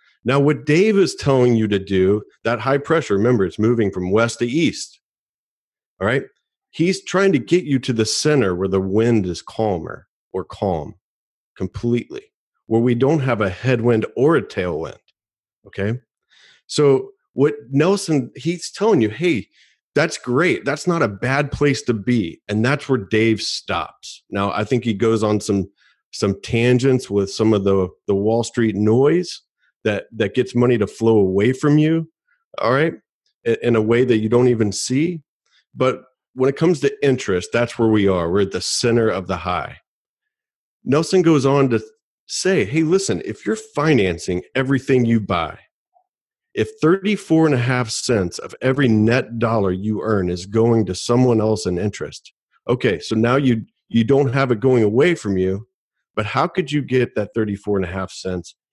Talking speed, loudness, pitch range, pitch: 180 wpm, -19 LUFS, 105-140 Hz, 120 Hz